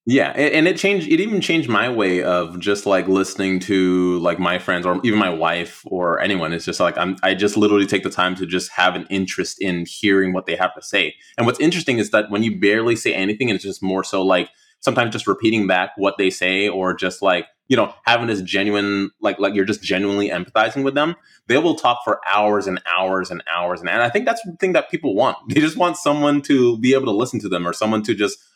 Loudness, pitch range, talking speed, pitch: -19 LUFS, 95-115 Hz, 245 wpm, 100 Hz